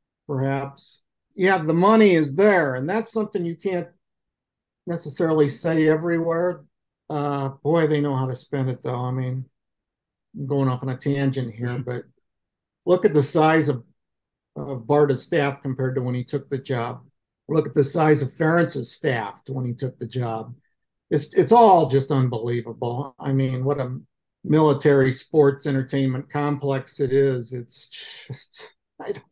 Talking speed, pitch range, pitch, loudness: 160 wpm, 130-155 Hz, 140 Hz, -22 LUFS